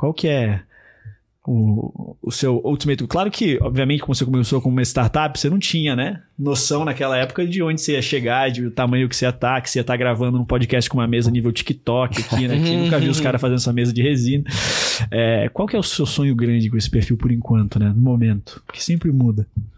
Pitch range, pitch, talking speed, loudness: 120-145 Hz, 125 Hz, 235 wpm, -19 LUFS